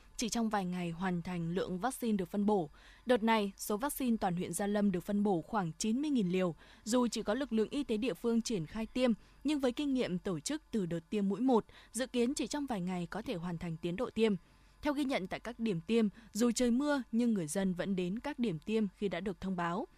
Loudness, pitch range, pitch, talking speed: -35 LUFS, 185-240 Hz, 215 Hz, 250 wpm